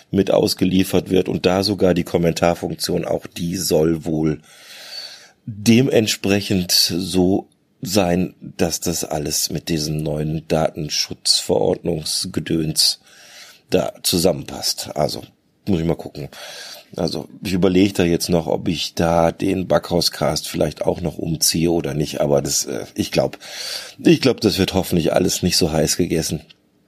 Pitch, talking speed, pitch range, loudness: 85 Hz, 135 wpm, 80-95 Hz, -19 LUFS